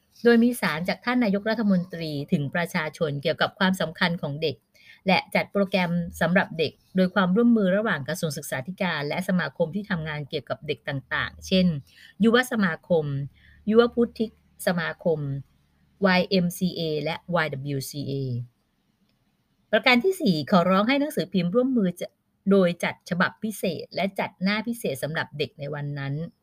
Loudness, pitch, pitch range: -25 LUFS, 180 Hz, 155-205 Hz